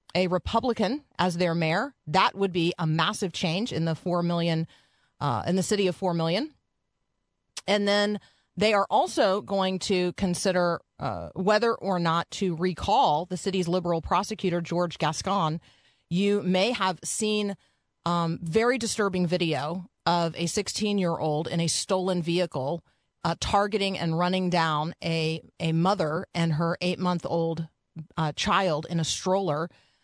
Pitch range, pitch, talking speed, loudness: 165-195 Hz, 180 Hz, 145 wpm, -26 LUFS